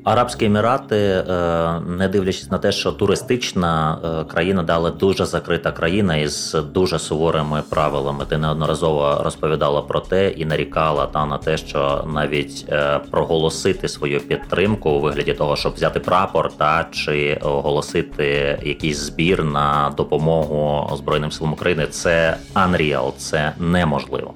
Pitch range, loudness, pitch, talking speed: 75-85 Hz, -19 LUFS, 80 Hz, 130 wpm